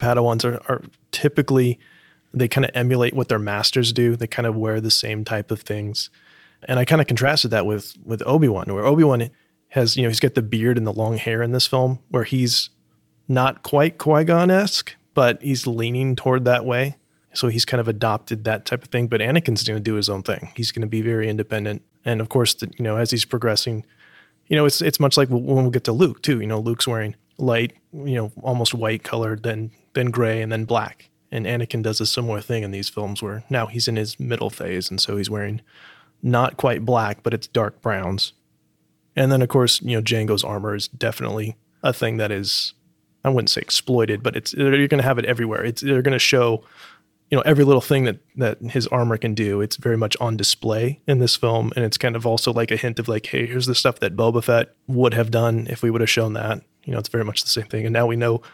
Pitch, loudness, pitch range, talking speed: 115 Hz, -21 LUFS, 110-130 Hz, 240 wpm